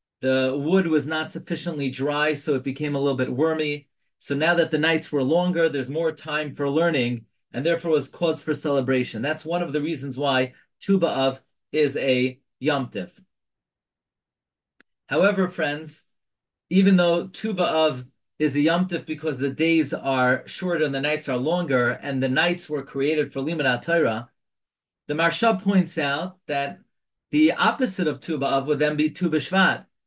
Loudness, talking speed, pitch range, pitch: -23 LUFS, 160 wpm, 135-165 Hz, 150 Hz